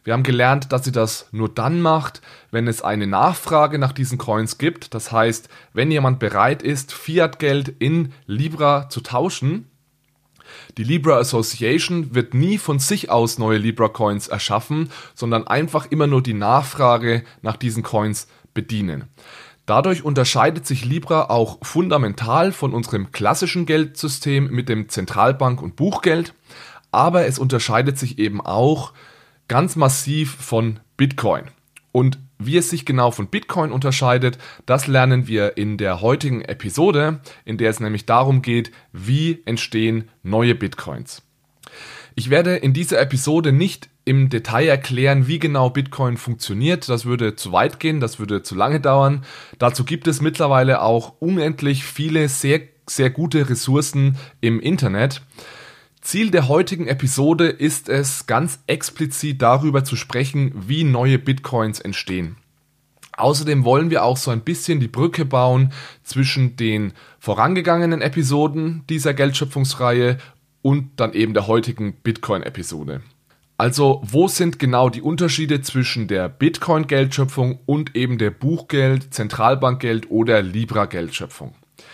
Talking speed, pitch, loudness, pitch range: 140 wpm, 135 Hz, -19 LUFS, 115-150 Hz